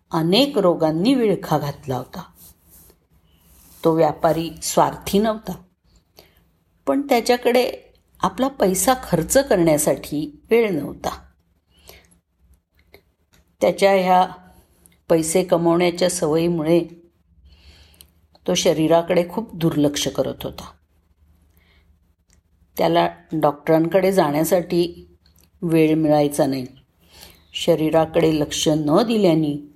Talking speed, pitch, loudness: 75 wpm, 150 Hz, -19 LUFS